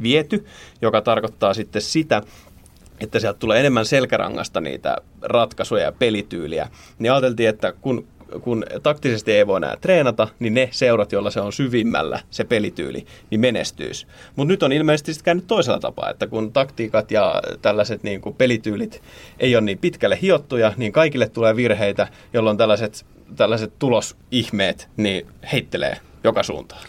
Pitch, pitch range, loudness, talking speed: 115 Hz, 105-135 Hz, -20 LUFS, 150 wpm